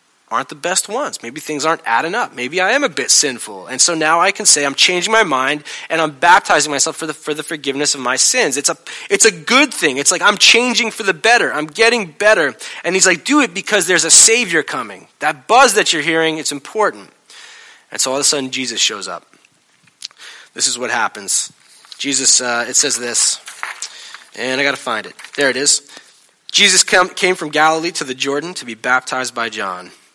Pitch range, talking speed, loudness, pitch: 140-205 Hz, 215 wpm, -14 LUFS, 160 Hz